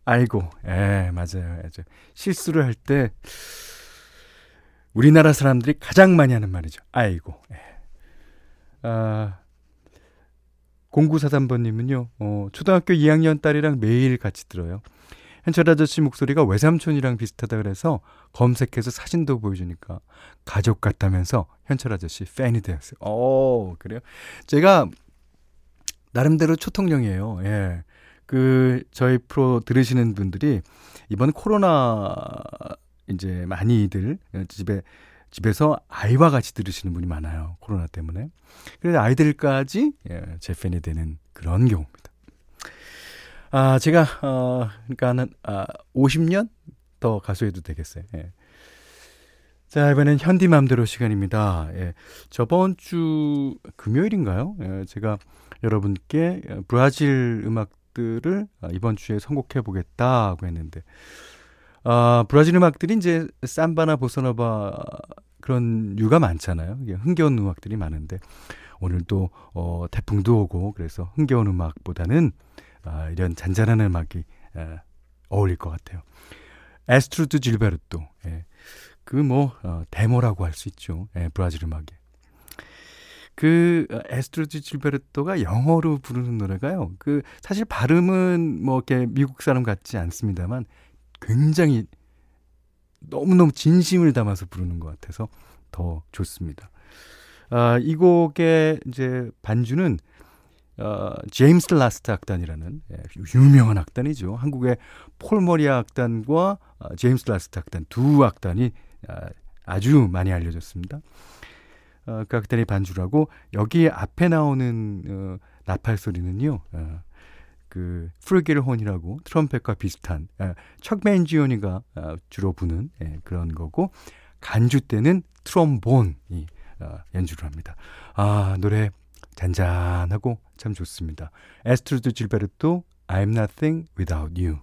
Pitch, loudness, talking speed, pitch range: 110 Hz, -21 LUFS, 270 characters per minute, 90-140 Hz